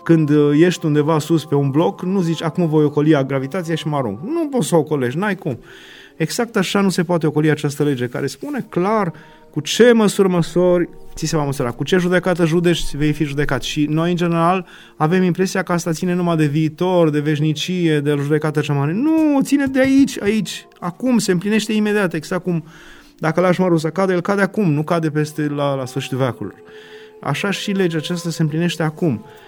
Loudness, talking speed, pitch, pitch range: -18 LUFS, 205 wpm, 170 Hz, 150-185 Hz